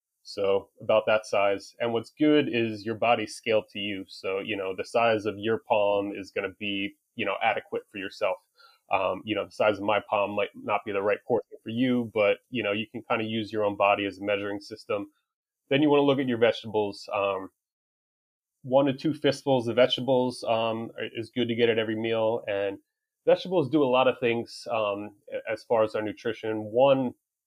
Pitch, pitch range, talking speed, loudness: 115 Hz, 105-150 Hz, 215 wpm, -27 LUFS